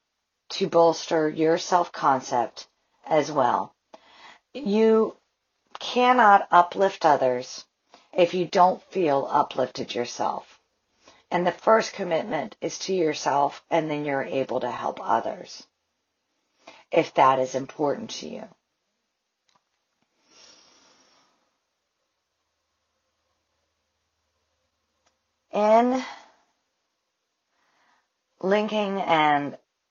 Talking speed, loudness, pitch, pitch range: 80 wpm, -23 LUFS, 170 Hz, 130-200 Hz